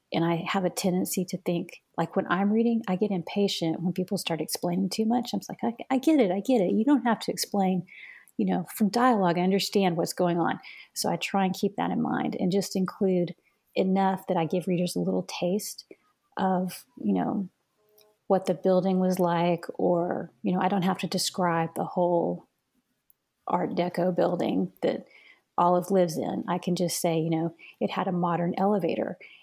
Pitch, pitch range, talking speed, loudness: 185 Hz, 175-200 Hz, 200 wpm, -27 LUFS